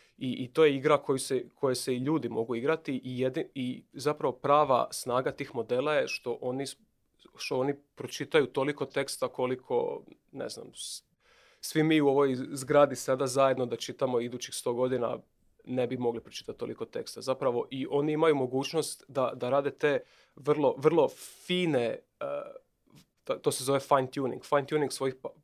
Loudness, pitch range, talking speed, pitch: -30 LUFS, 130-155 Hz, 170 wpm, 140 Hz